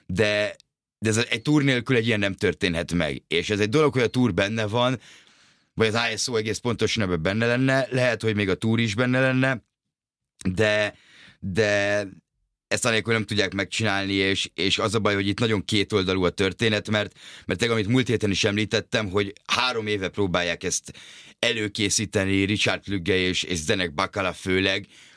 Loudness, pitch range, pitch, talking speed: -23 LUFS, 95-115 Hz, 105 Hz, 175 wpm